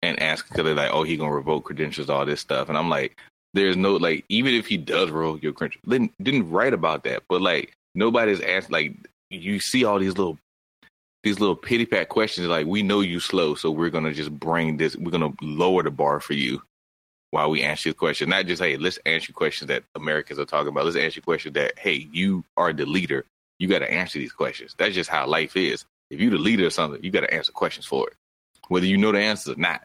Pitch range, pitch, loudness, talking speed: 75-100 Hz, 85 Hz, -23 LUFS, 245 wpm